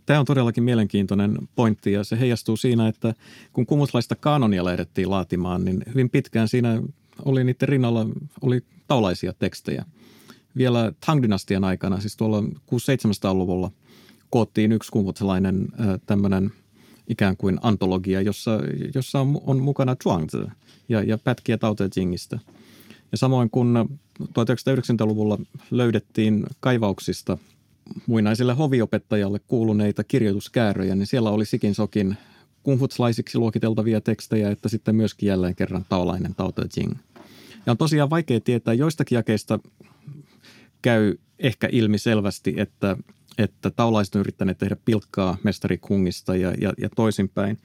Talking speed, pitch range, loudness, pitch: 130 wpm, 100-125 Hz, -23 LUFS, 110 Hz